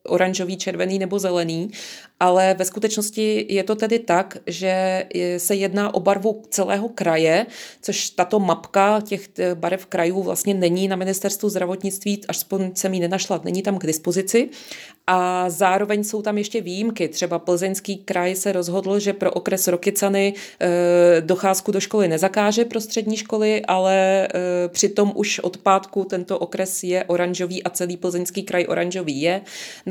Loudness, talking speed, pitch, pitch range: -21 LUFS, 150 wpm, 190 Hz, 180-205 Hz